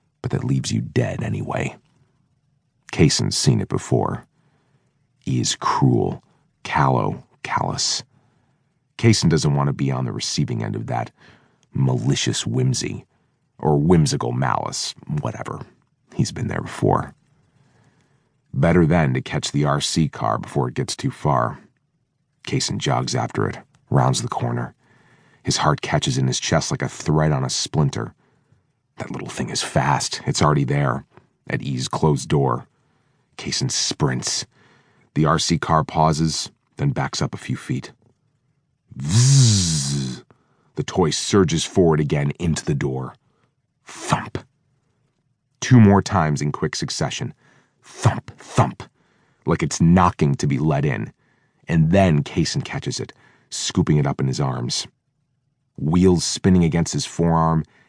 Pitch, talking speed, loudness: 100 Hz, 135 wpm, -21 LUFS